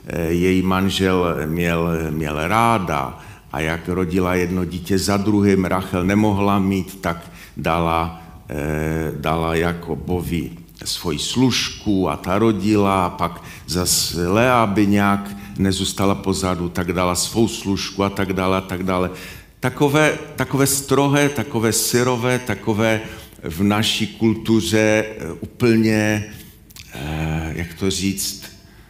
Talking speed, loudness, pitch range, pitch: 115 wpm, -19 LUFS, 85-110 Hz, 95 Hz